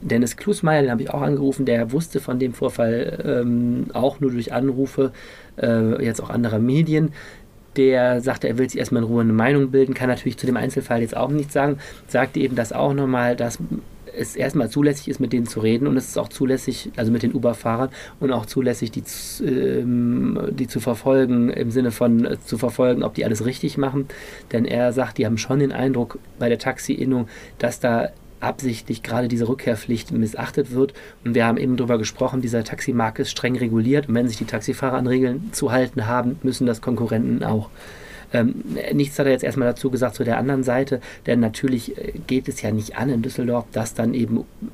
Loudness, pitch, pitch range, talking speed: -21 LUFS, 125 Hz, 115-135 Hz, 205 wpm